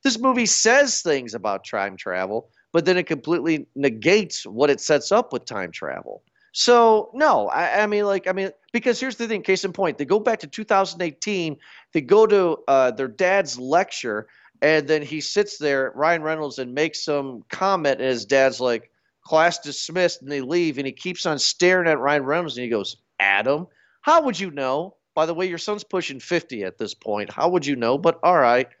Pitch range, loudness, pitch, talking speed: 140-195 Hz, -21 LUFS, 165 Hz, 205 wpm